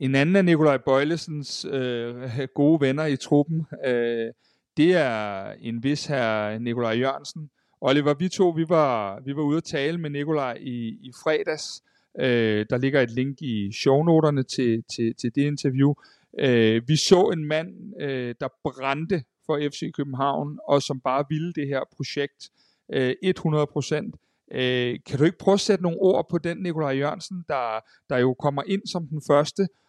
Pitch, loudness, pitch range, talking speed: 145 Hz, -24 LUFS, 130-155 Hz, 175 wpm